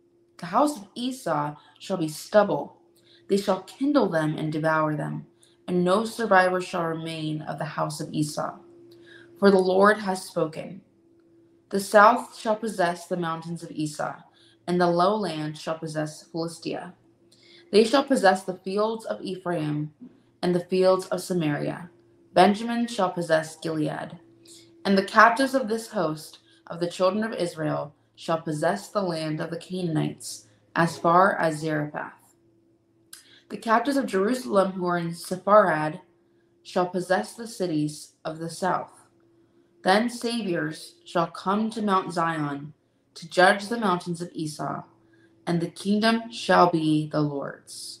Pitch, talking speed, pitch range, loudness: 180 Hz, 145 wpm, 155-205 Hz, -25 LUFS